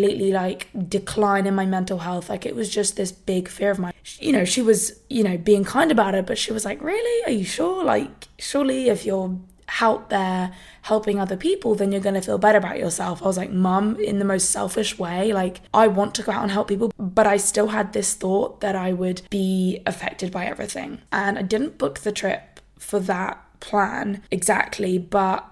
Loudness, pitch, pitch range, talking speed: -22 LUFS, 200 Hz, 190-215 Hz, 215 wpm